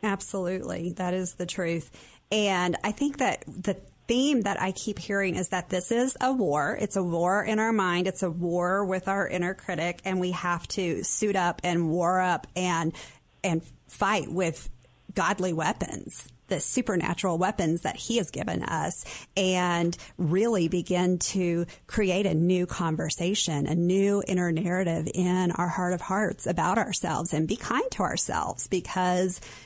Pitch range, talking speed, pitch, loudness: 175-195 Hz, 165 wpm, 185 Hz, -27 LUFS